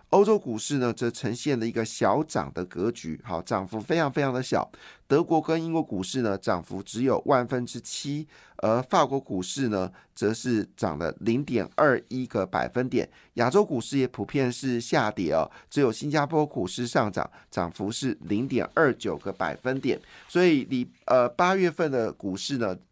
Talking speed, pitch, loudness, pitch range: 265 characters per minute, 125 Hz, -27 LUFS, 110-145 Hz